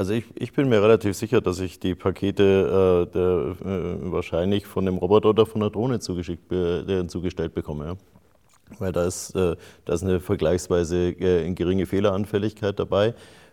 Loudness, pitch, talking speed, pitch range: -23 LUFS, 95 Hz, 170 wpm, 90-105 Hz